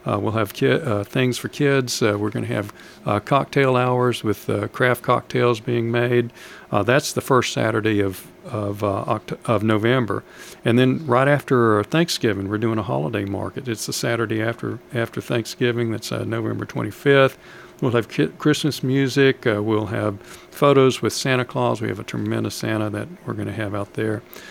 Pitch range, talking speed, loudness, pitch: 105-125 Hz, 190 wpm, -21 LUFS, 115 Hz